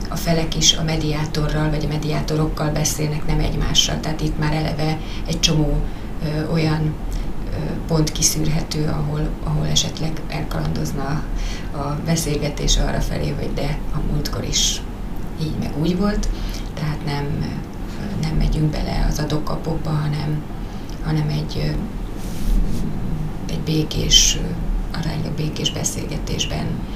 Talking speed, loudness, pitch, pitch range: 120 wpm, -22 LUFS, 155 Hz, 150-155 Hz